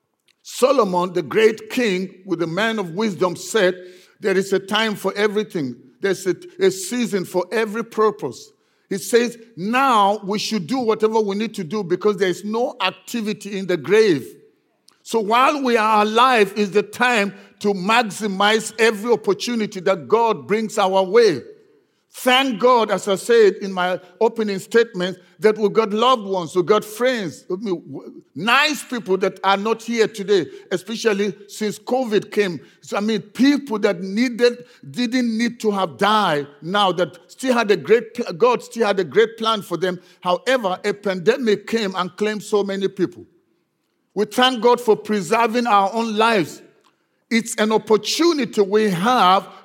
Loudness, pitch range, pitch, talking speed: -19 LUFS, 190-230 Hz, 210 Hz, 160 wpm